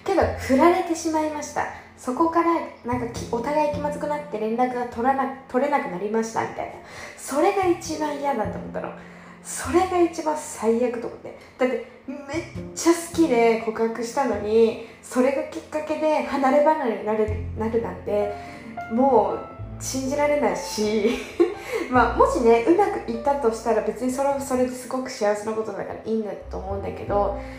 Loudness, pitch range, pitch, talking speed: -23 LUFS, 225-305 Hz, 260 Hz, 350 characters per minute